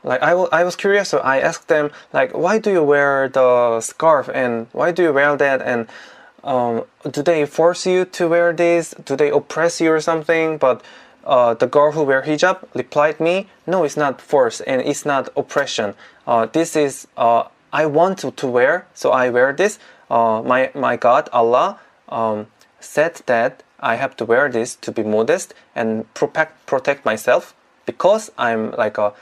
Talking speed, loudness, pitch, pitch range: 190 wpm, -18 LUFS, 145 Hz, 120-165 Hz